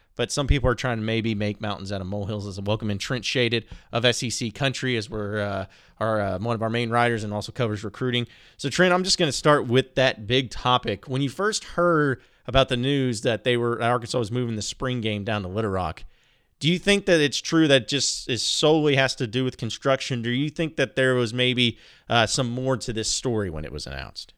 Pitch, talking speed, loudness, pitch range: 120 Hz, 240 wpm, -24 LUFS, 110-135 Hz